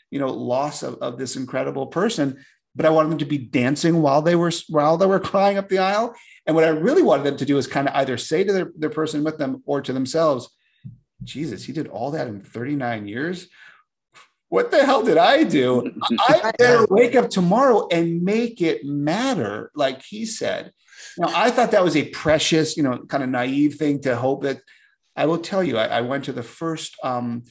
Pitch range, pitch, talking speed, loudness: 140-195 Hz, 155 Hz, 220 wpm, -20 LUFS